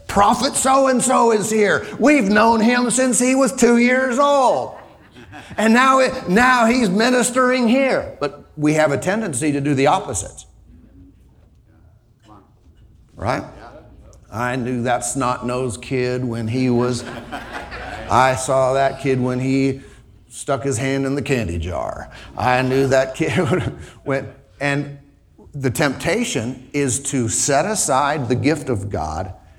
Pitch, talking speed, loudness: 135 Hz, 140 wpm, -18 LUFS